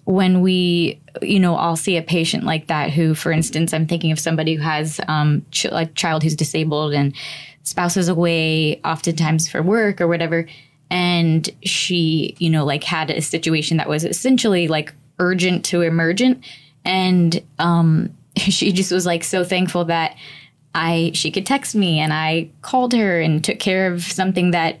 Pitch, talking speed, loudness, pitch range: 165 Hz, 175 wpm, -18 LUFS, 160-185 Hz